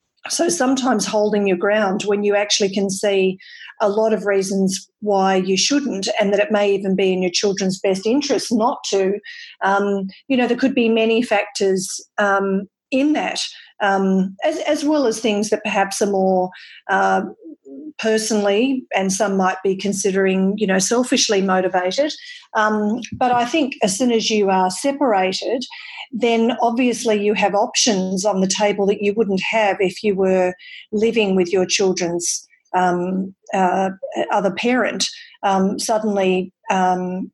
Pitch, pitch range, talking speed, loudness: 205 Hz, 190-235 Hz, 160 wpm, -19 LUFS